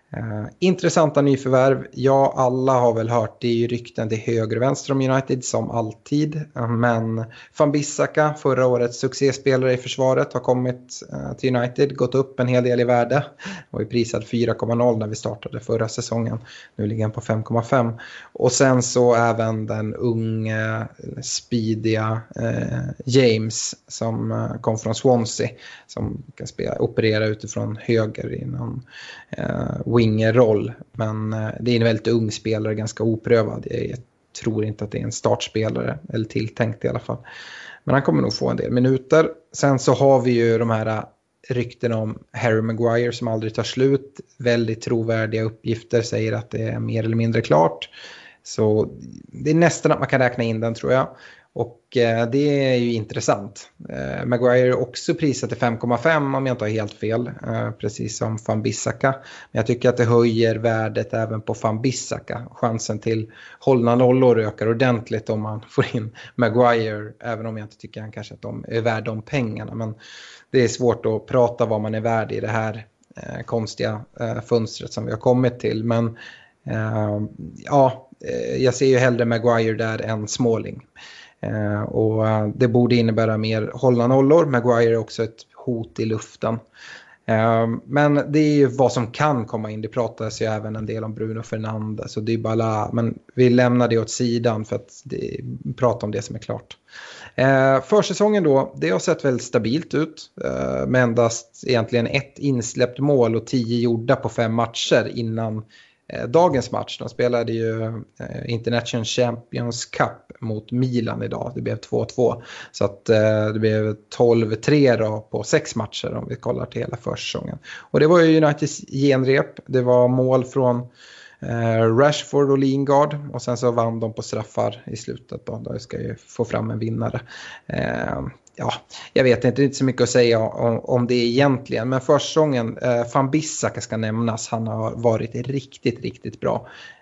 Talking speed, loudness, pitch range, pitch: 170 wpm, -21 LUFS, 110-130 Hz, 120 Hz